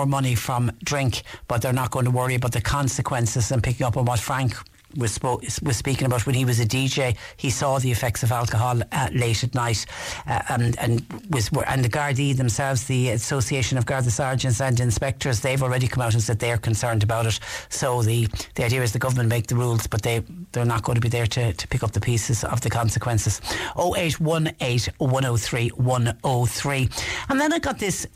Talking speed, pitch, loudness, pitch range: 205 wpm, 125 Hz, -23 LUFS, 115-130 Hz